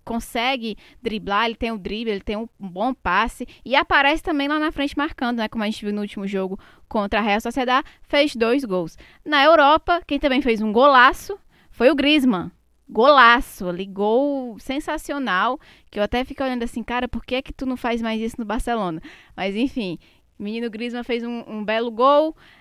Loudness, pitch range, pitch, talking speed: -20 LUFS, 215-280 Hz, 240 Hz, 195 wpm